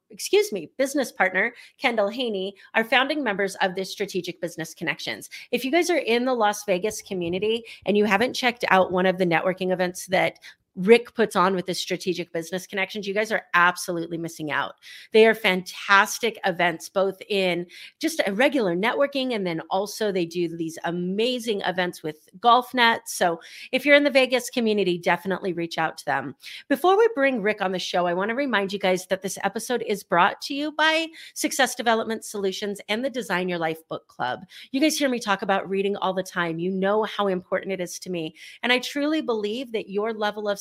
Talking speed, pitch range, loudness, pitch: 205 wpm, 180-235 Hz, -24 LUFS, 200 Hz